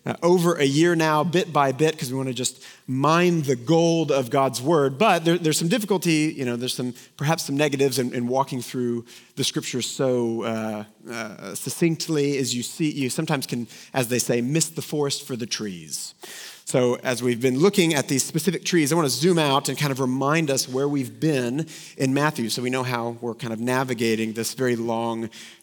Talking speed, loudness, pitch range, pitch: 215 wpm, -23 LUFS, 125-155 Hz, 135 Hz